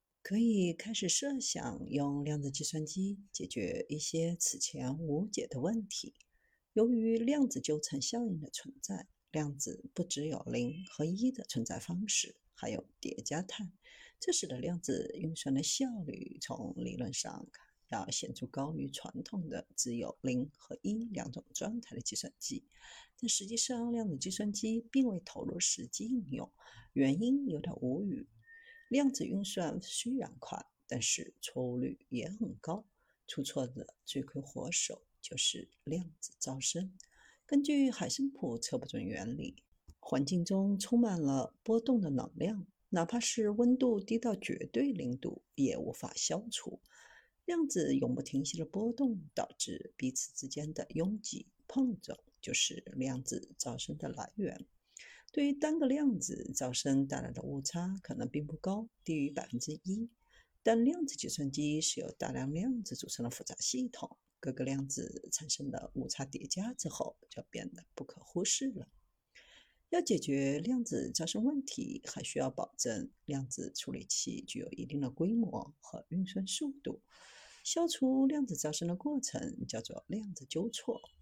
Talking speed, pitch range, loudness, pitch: 230 characters per minute, 150-245 Hz, -36 LUFS, 200 Hz